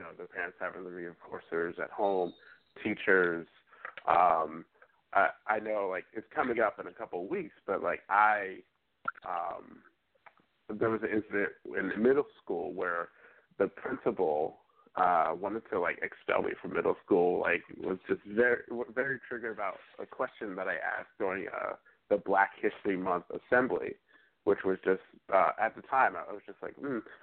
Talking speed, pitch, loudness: 170 wpm, 110 Hz, -32 LUFS